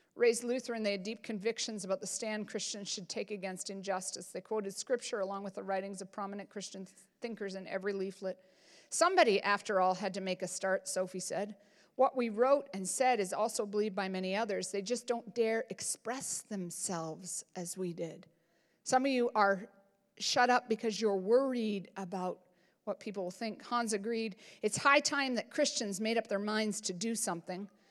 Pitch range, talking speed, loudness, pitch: 190-230 Hz, 185 wpm, -34 LUFS, 205 Hz